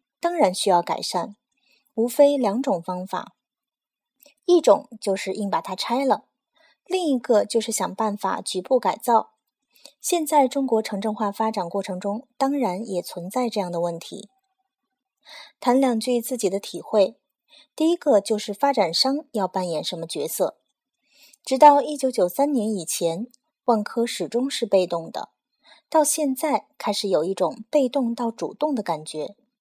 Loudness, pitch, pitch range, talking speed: -23 LUFS, 240 Hz, 200-285 Hz, 225 characters per minute